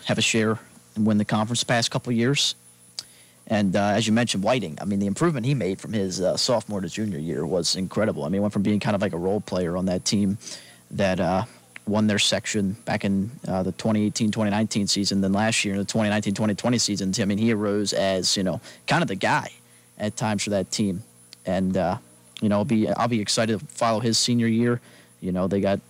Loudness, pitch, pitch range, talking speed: -24 LUFS, 105 Hz, 95-110 Hz, 230 wpm